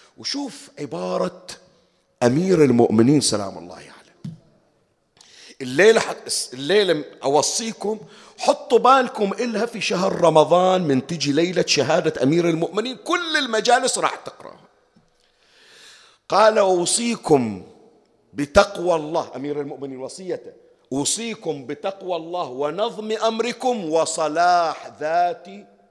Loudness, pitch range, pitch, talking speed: -20 LUFS, 150-230 Hz, 180 Hz, 95 wpm